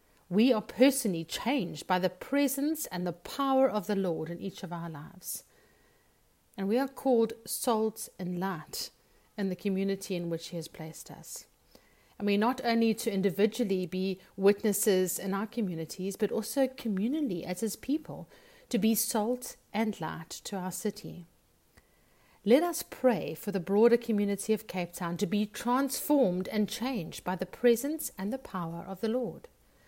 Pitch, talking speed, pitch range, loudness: 205 Hz, 165 wpm, 185-235 Hz, -31 LUFS